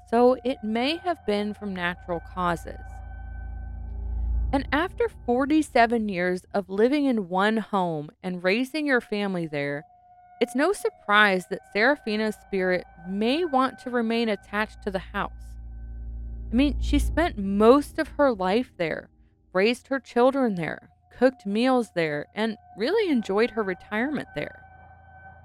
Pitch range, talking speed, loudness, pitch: 175-255 Hz, 135 wpm, -25 LUFS, 215 Hz